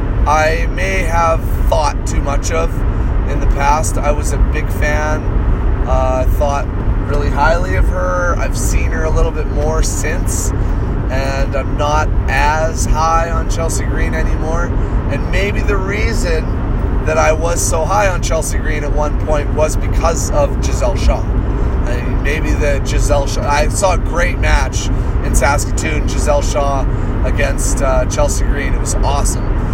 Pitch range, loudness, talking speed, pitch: 90-110 Hz, -16 LUFS, 165 wpm, 100 Hz